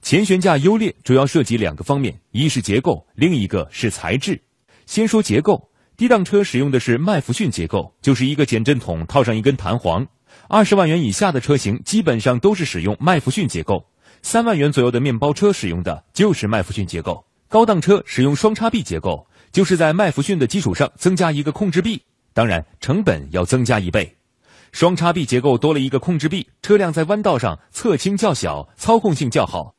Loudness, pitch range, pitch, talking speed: -18 LUFS, 115-190 Hz, 140 Hz, 310 characters per minute